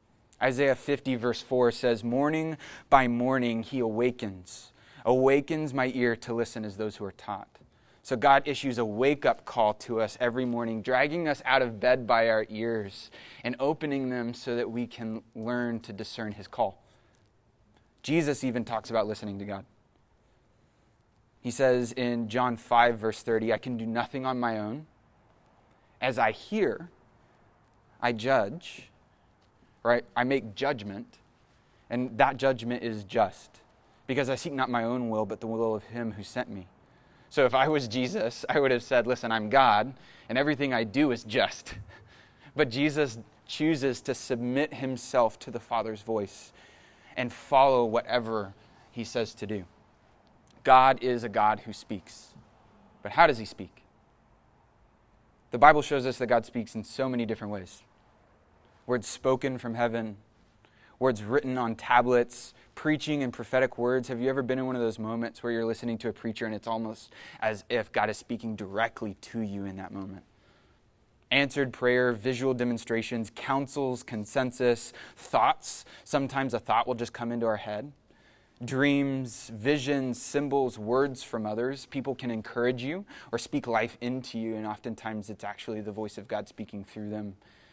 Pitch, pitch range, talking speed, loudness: 120 Hz, 110-130 Hz, 165 wpm, -29 LUFS